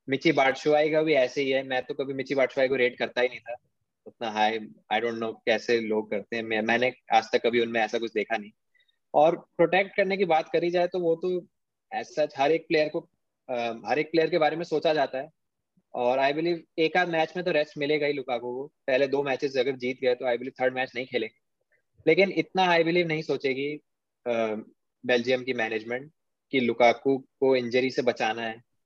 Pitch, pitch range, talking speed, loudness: 135 Hz, 120-160 Hz, 215 wpm, -26 LUFS